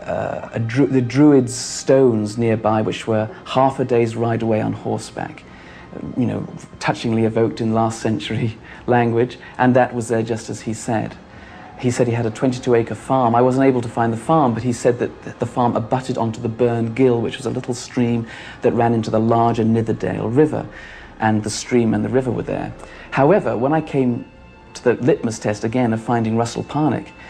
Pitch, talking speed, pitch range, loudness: 115 Hz, 205 wpm, 110-125 Hz, -19 LUFS